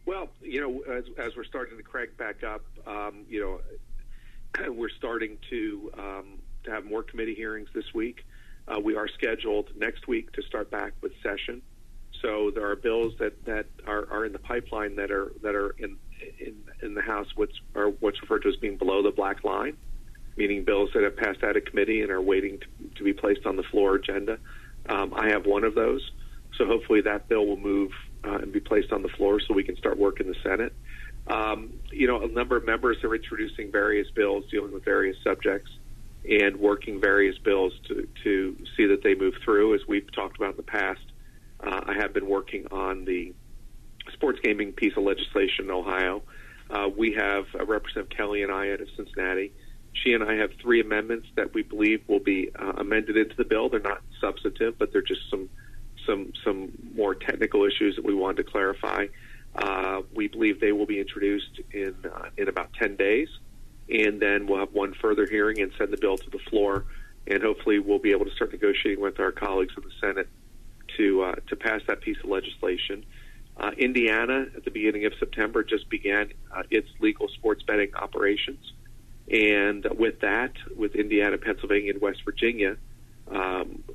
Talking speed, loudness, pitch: 200 wpm, -27 LUFS, 330 Hz